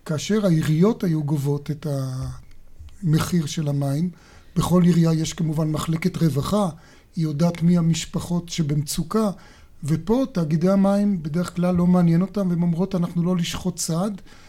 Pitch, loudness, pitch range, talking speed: 170 Hz, -22 LUFS, 155-180 Hz, 135 wpm